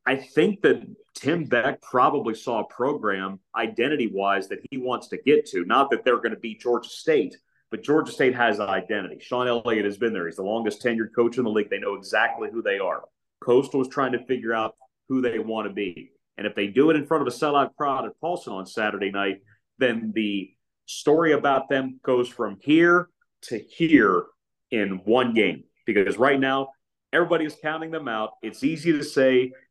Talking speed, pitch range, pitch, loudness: 205 wpm, 110-155 Hz, 130 Hz, -24 LUFS